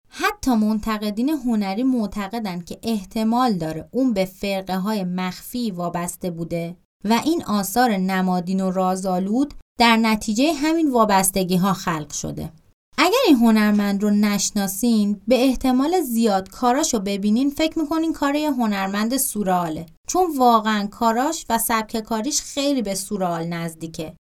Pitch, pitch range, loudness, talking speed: 215 Hz, 190-250 Hz, -21 LUFS, 135 wpm